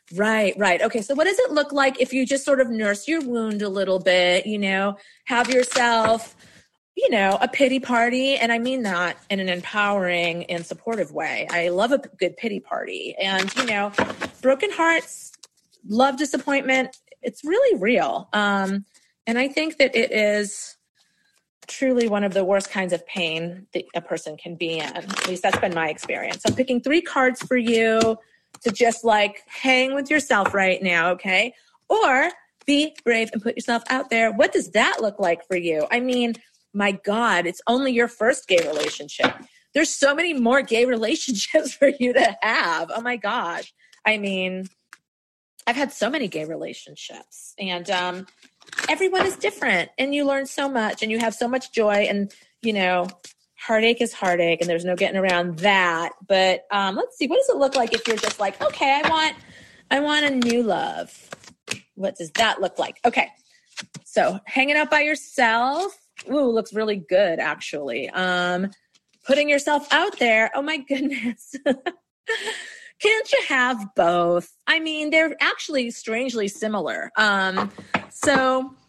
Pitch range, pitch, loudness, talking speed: 195-275 Hz, 230 Hz, -21 LUFS, 175 wpm